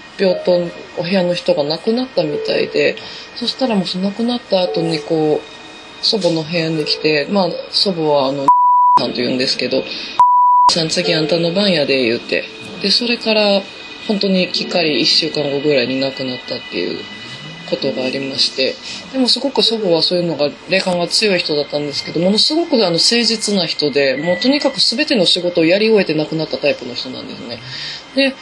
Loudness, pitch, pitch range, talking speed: -15 LUFS, 180 Hz, 155-230 Hz, 385 characters per minute